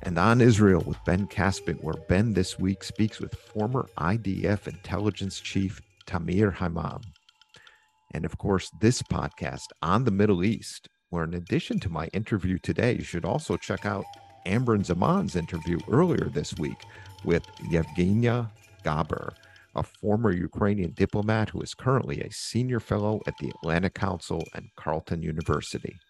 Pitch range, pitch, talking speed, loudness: 90-110 Hz, 100 Hz, 150 wpm, -27 LUFS